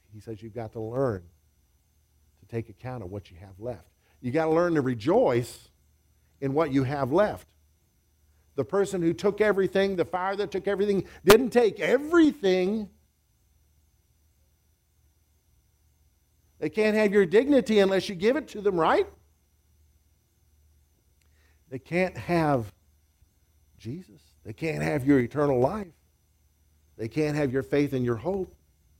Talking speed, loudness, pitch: 140 wpm, -25 LUFS, 110 Hz